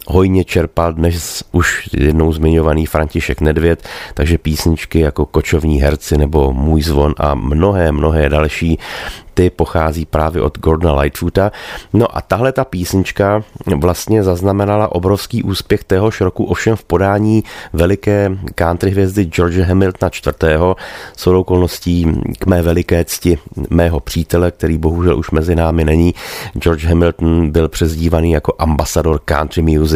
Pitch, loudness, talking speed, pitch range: 85 Hz, -14 LUFS, 135 wpm, 80-95 Hz